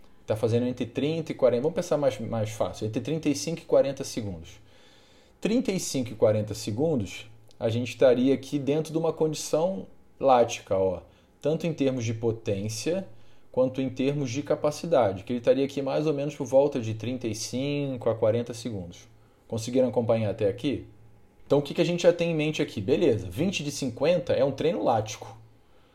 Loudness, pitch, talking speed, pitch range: -27 LUFS, 125 Hz, 180 wpm, 110-145 Hz